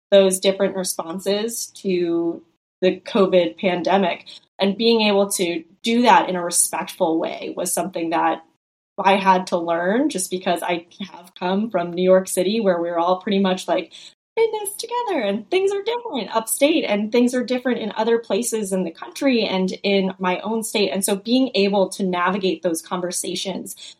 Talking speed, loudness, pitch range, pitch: 175 wpm, -20 LUFS, 180-225 Hz, 195 Hz